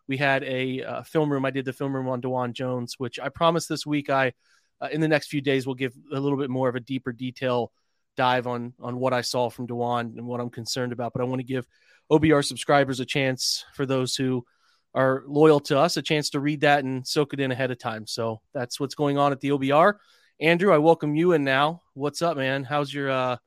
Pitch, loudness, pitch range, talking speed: 135 Hz, -25 LUFS, 125-145 Hz, 250 wpm